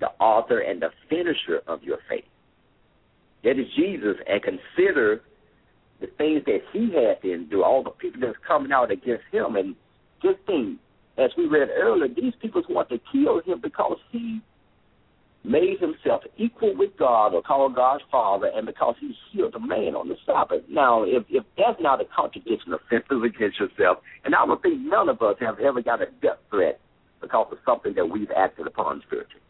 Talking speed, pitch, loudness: 185 wpm, 360 Hz, -24 LUFS